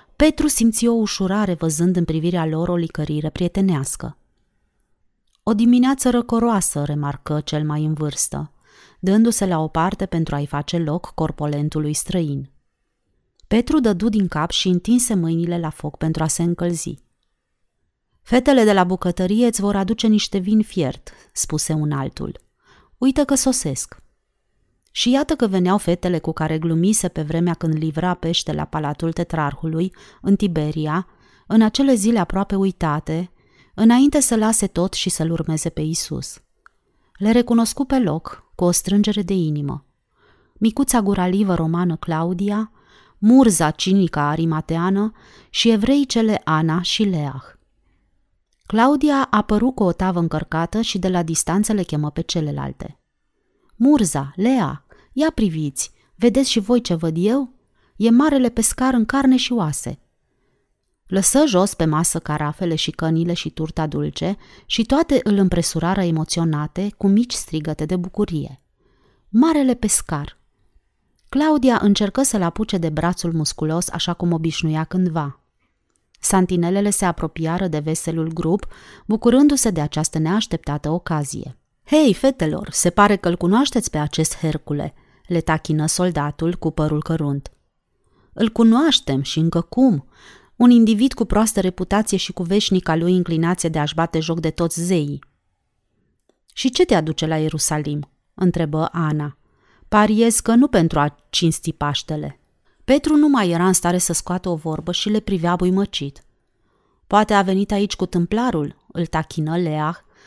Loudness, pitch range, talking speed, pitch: -19 LUFS, 160-215 Hz, 145 wpm, 175 Hz